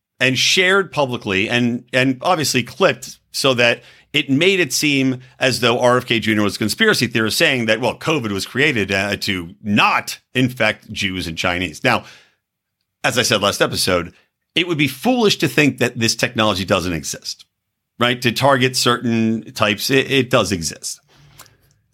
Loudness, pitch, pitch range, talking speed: -17 LUFS, 125 Hz, 110-135 Hz, 165 wpm